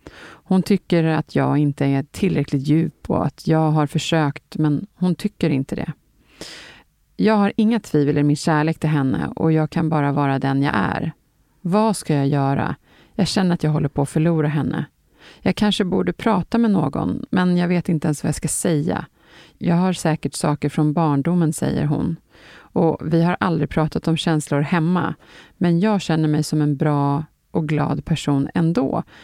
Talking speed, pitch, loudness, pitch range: 185 wpm, 160 Hz, -20 LUFS, 145-175 Hz